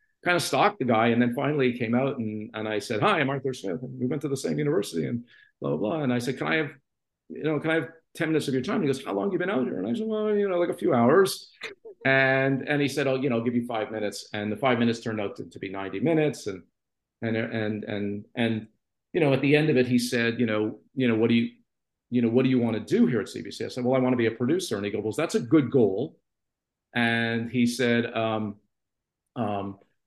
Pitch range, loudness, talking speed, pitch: 110-145 Hz, -26 LUFS, 285 wpm, 125 Hz